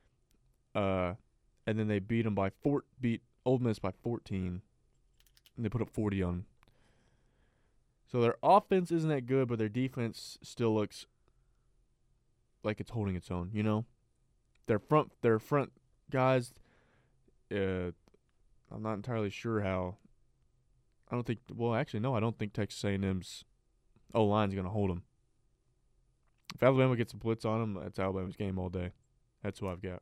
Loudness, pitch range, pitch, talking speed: -34 LUFS, 100-125 Hz, 115 Hz, 165 wpm